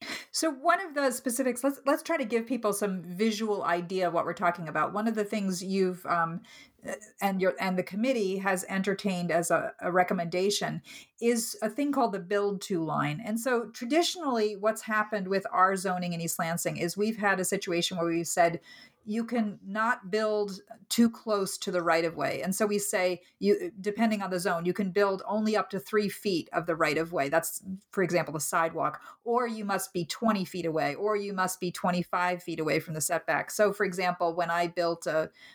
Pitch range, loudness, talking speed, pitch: 175-220 Hz, -29 LUFS, 210 wpm, 195 Hz